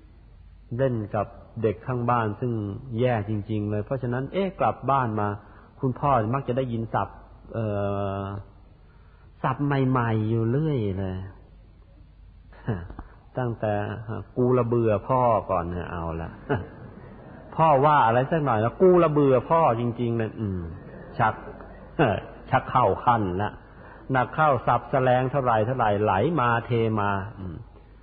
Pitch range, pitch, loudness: 100-125 Hz, 110 Hz, -25 LUFS